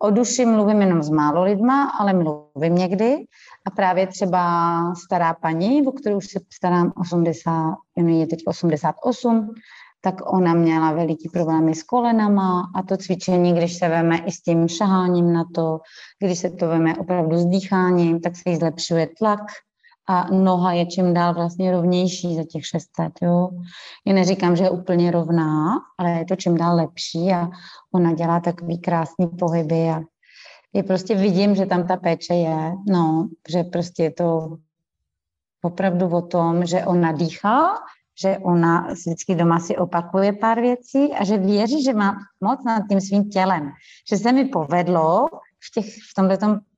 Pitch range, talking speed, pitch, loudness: 165-195 Hz, 165 wpm, 180 Hz, -20 LUFS